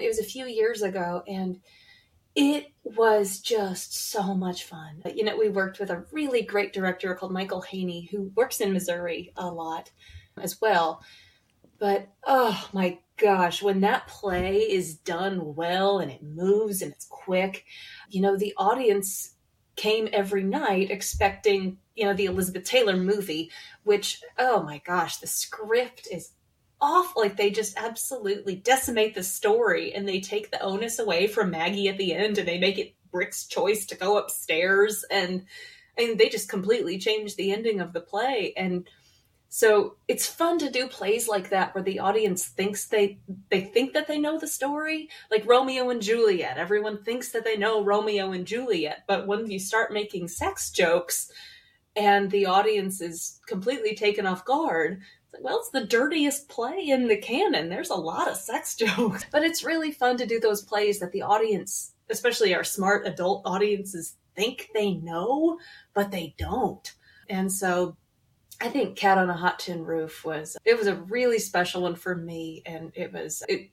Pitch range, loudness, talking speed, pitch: 185-230 Hz, -26 LUFS, 175 wpm, 205 Hz